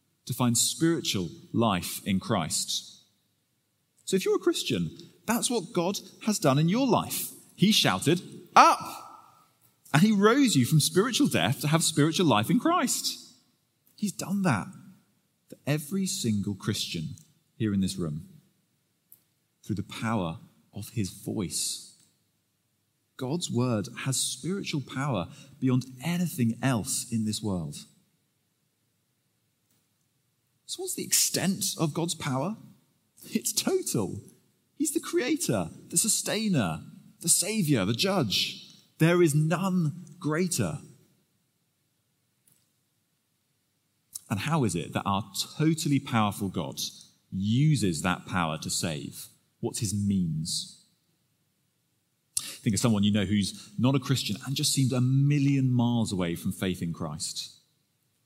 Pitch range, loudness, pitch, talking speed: 115-180 Hz, -27 LUFS, 145 Hz, 125 wpm